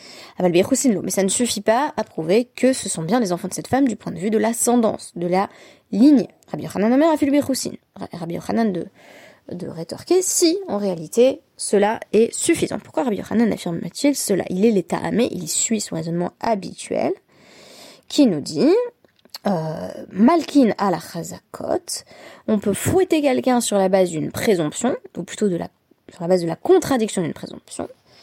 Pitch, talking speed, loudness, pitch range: 220 Hz, 170 wpm, -20 LUFS, 190-270 Hz